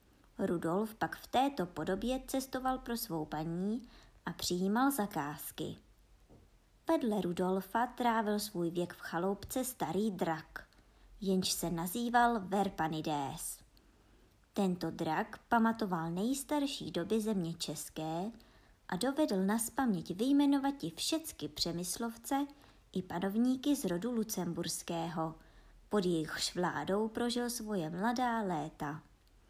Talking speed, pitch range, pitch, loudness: 105 wpm, 165-235 Hz, 195 Hz, -35 LUFS